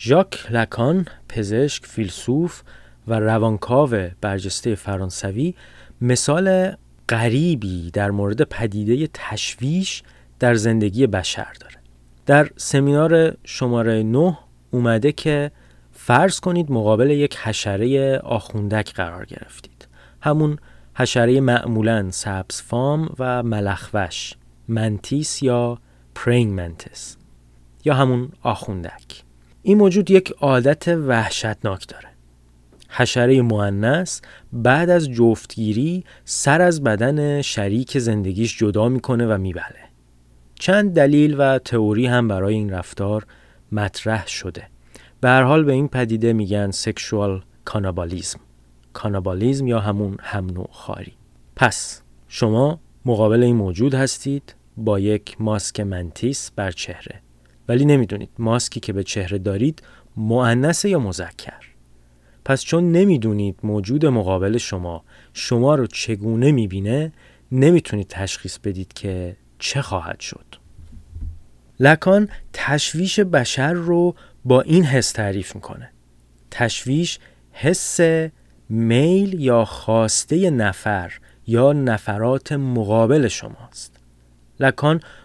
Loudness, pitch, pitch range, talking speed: -19 LUFS, 115 Hz, 95-140 Hz, 105 wpm